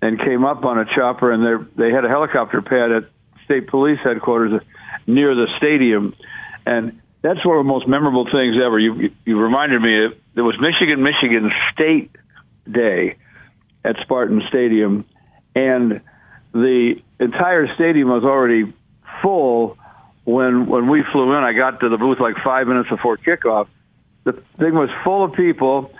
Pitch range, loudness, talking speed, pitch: 115-135 Hz, -17 LUFS, 165 wpm, 125 Hz